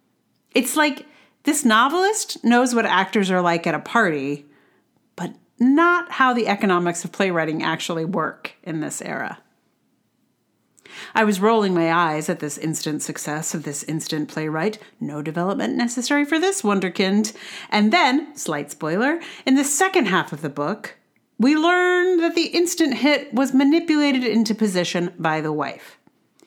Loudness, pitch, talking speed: -20 LUFS, 215 Hz, 150 wpm